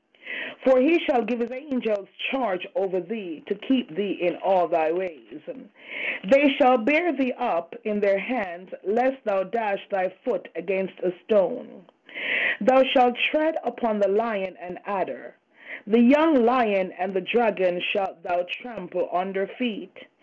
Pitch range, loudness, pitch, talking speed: 190-255 Hz, -24 LUFS, 220 Hz, 150 wpm